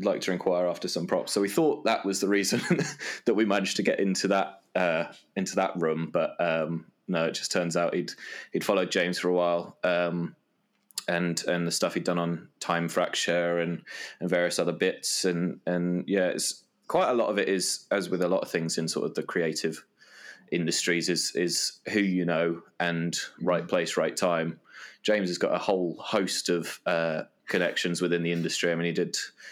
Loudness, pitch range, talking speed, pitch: -28 LUFS, 85-90 Hz, 205 wpm, 85 Hz